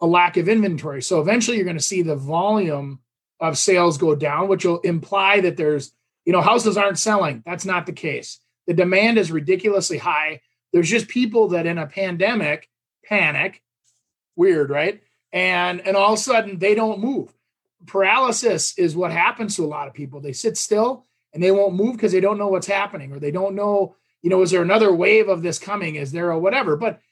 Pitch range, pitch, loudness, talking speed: 160-205 Hz, 185 Hz, -19 LUFS, 210 wpm